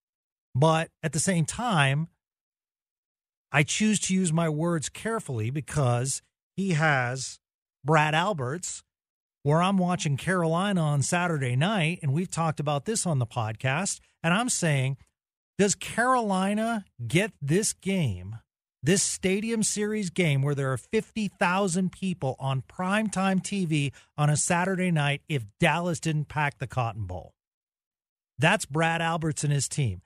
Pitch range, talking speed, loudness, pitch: 140-185 Hz, 140 wpm, -26 LUFS, 160 Hz